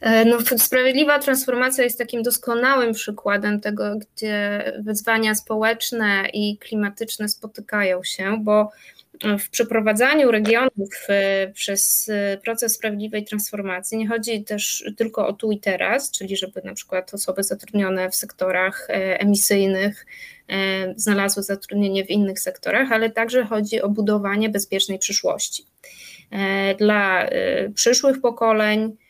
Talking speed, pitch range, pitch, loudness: 115 wpm, 200-230 Hz, 210 Hz, -20 LUFS